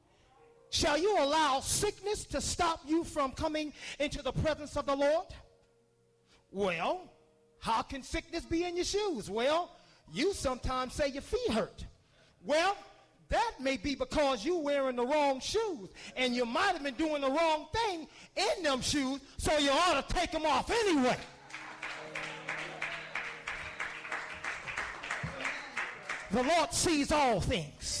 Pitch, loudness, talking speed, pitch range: 300 Hz, -33 LUFS, 140 wpm, 270-340 Hz